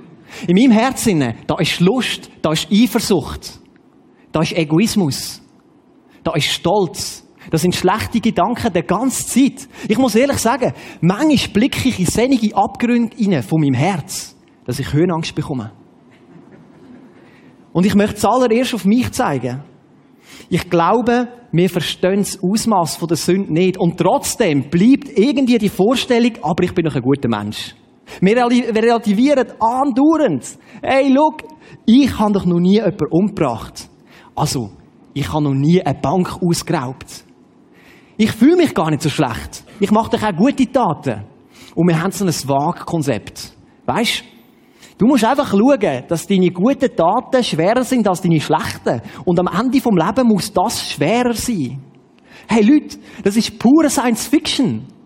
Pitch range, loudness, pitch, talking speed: 160-240 Hz, -16 LUFS, 195 Hz, 150 wpm